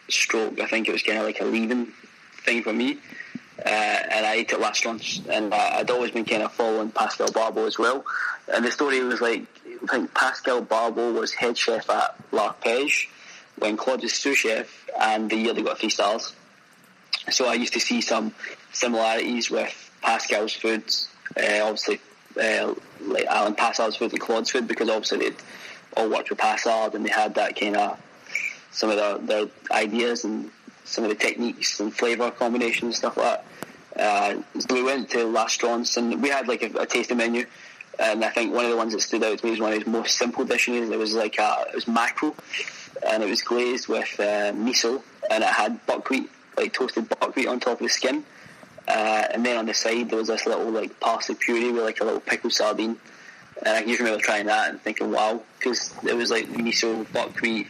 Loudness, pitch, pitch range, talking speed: -24 LUFS, 115 Hz, 110-120 Hz, 210 wpm